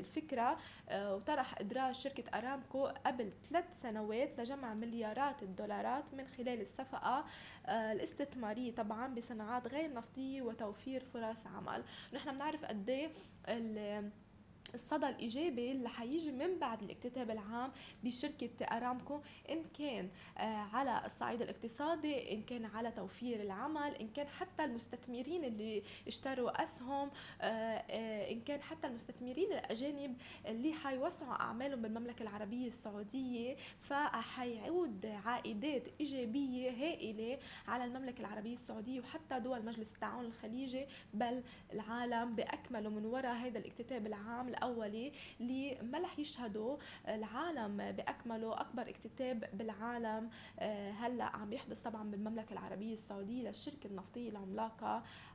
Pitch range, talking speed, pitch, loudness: 220-270 Hz, 110 wpm, 245 Hz, -43 LUFS